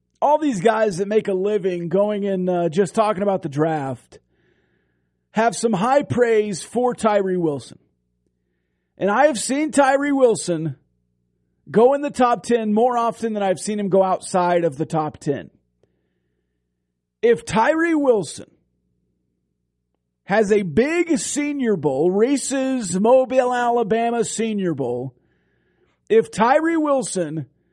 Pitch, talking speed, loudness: 200 Hz, 130 wpm, -20 LUFS